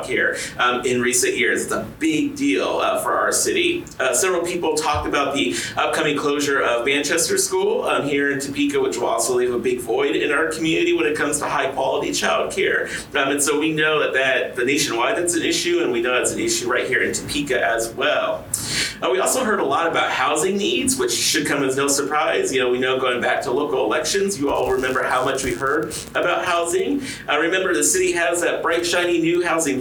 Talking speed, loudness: 225 wpm, -19 LUFS